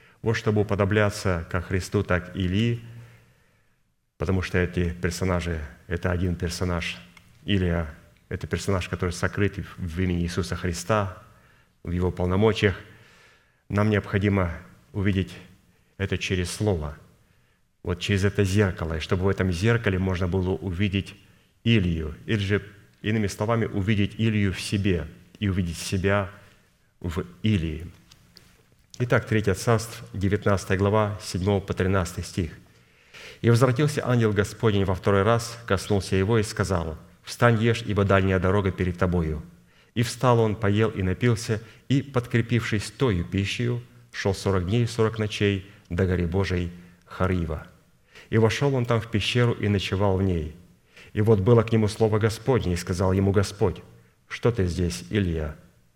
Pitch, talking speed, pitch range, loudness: 100 Hz, 140 wpm, 90-110 Hz, -25 LUFS